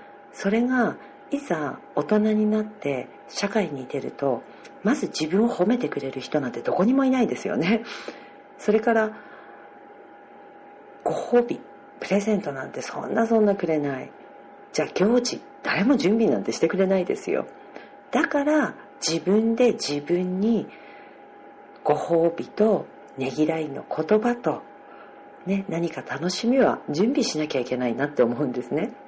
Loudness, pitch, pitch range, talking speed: -24 LUFS, 200 Hz, 155-225 Hz, 280 characters per minute